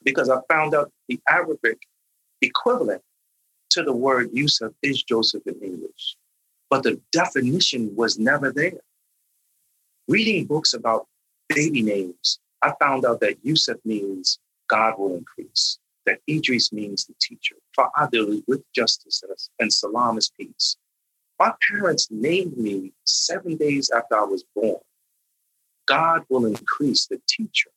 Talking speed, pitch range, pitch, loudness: 135 wpm, 110-165 Hz, 135 Hz, -22 LUFS